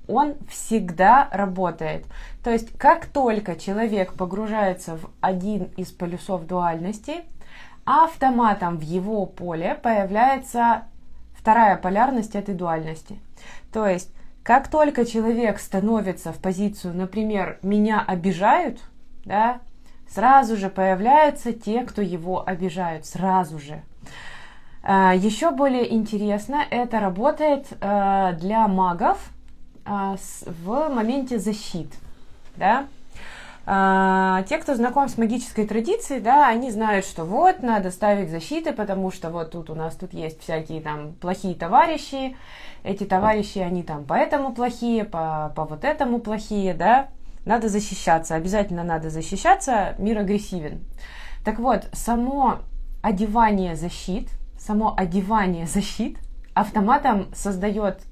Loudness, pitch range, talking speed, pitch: -22 LUFS, 185-235 Hz, 115 wpm, 205 Hz